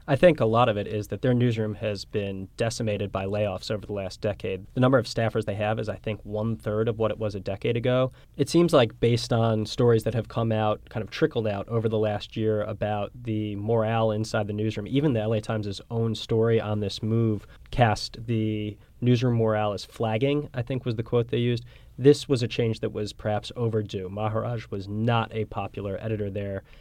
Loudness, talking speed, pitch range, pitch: -26 LUFS, 220 wpm, 105-120 Hz, 110 Hz